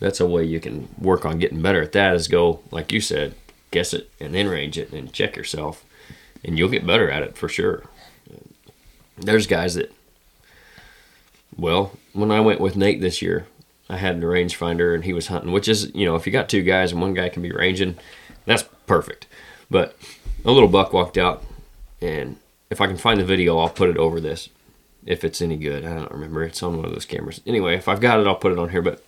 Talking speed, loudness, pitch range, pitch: 235 wpm, -21 LUFS, 85-95 Hz, 90 Hz